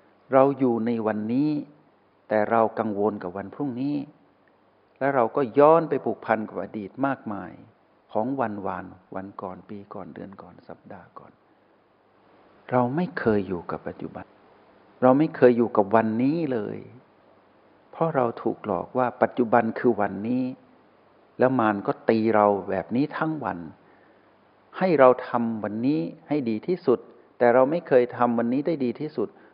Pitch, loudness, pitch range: 120 Hz, -24 LUFS, 105-135 Hz